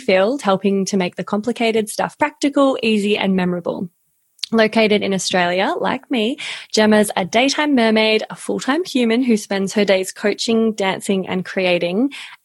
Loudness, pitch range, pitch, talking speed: -18 LUFS, 195-230 Hz, 215 Hz, 155 wpm